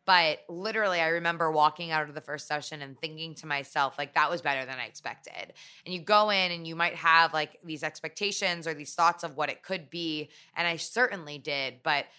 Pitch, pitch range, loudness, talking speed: 160 Hz, 150-170 Hz, -28 LUFS, 220 wpm